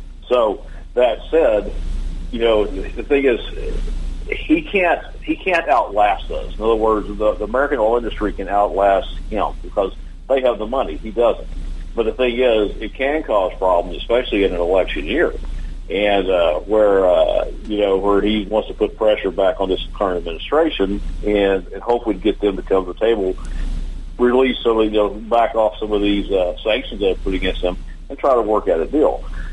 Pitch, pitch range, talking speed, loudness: 105 Hz, 95-120 Hz, 190 wpm, -18 LUFS